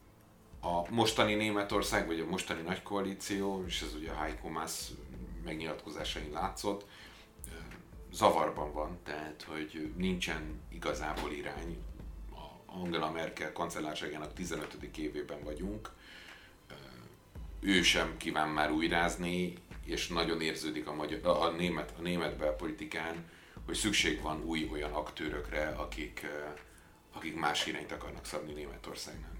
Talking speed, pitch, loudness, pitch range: 120 wpm, 85 Hz, -35 LUFS, 75-90 Hz